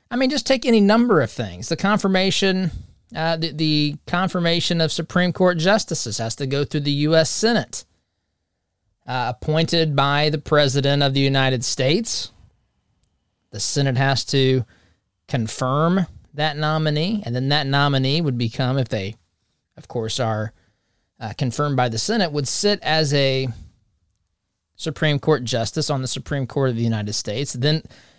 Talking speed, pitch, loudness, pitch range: 155 wpm, 140 Hz, -20 LUFS, 115-160 Hz